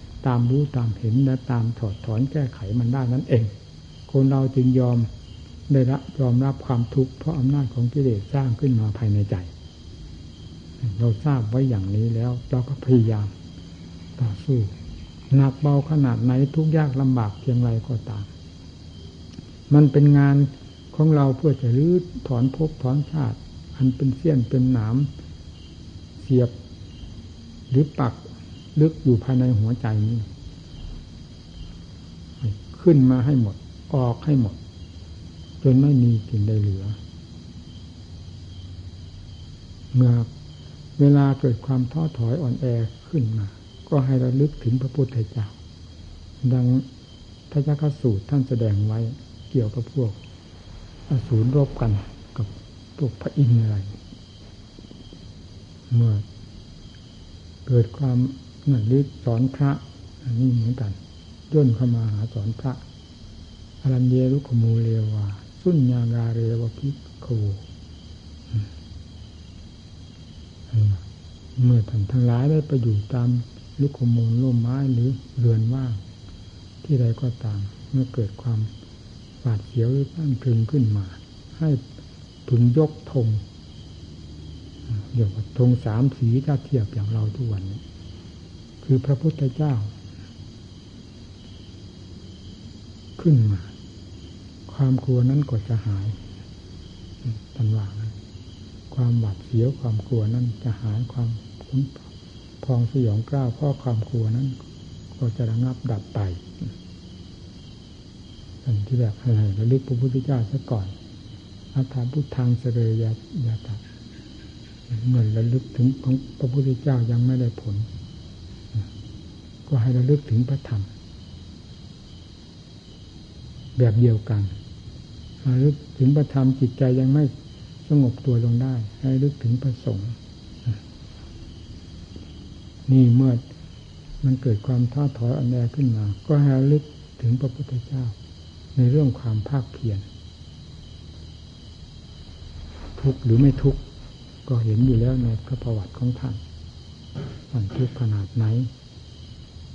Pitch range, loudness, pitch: 100-130 Hz, -22 LUFS, 115 Hz